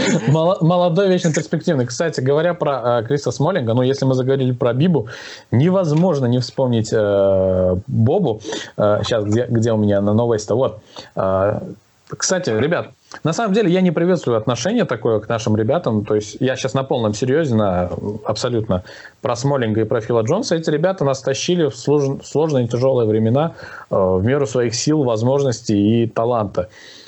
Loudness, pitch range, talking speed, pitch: -18 LUFS, 110-150 Hz, 170 wpm, 125 Hz